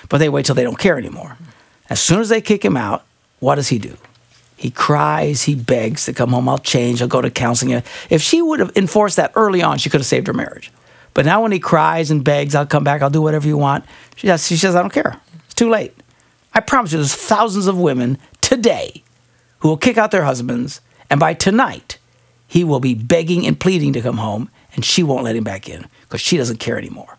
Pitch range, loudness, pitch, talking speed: 130-190 Hz, -16 LUFS, 155 Hz, 235 wpm